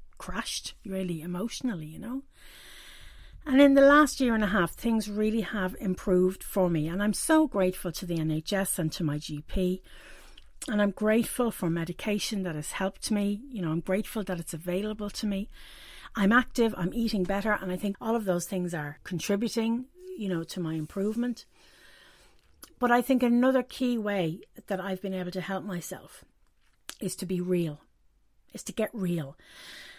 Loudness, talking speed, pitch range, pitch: -28 LUFS, 175 wpm, 180-230 Hz, 195 Hz